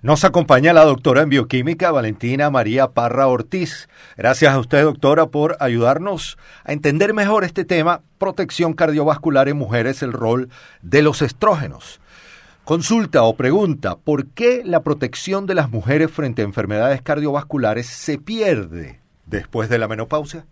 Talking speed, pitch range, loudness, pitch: 145 wpm, 130-165 Hz, -17 LUFS, 145 Hz